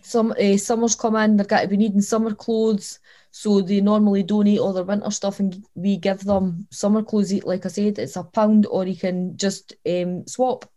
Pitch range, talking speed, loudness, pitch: 195-215 Hz, 210 wpm, -21 LUFS, 205 Hz